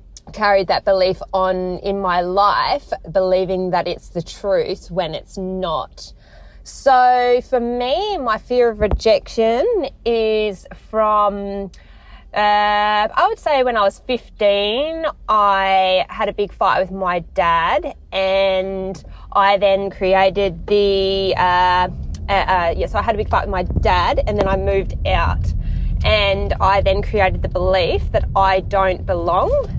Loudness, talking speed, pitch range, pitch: -17 LUFS, 150 wpm, 185-215 Hz, 195 Hz